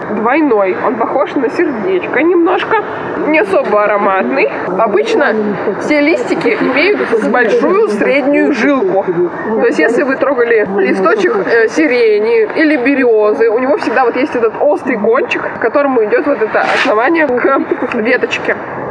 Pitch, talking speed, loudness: 300 Hz, 130 wpm, -12 LUFS